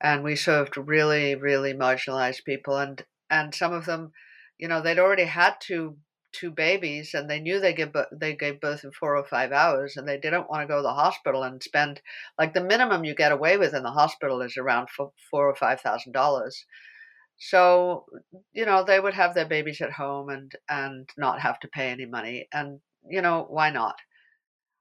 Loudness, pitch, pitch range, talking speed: -25 LUFS, 150 Hz, 140-175 Hz, 200 wpm